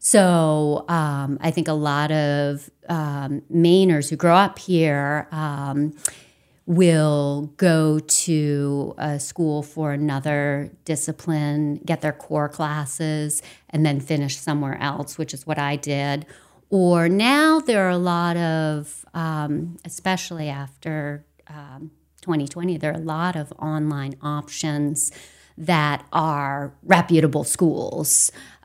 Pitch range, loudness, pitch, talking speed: 145-165 Hz, -21 LUFS, 155 Hz, 125 wpm